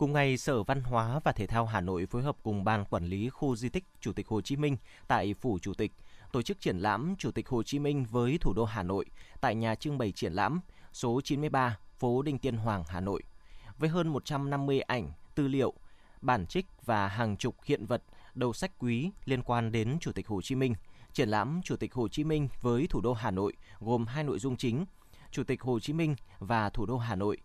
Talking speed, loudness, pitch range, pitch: 235 wpm, -33 LUFS, 105-140 Hz, 120 Hz